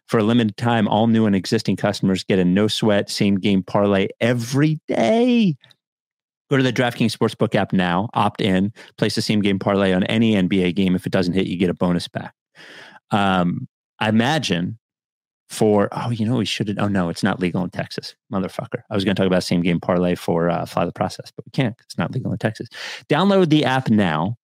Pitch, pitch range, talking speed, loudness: 105 Hz, 95-115 Hz, 205 wpm, -20 LUFS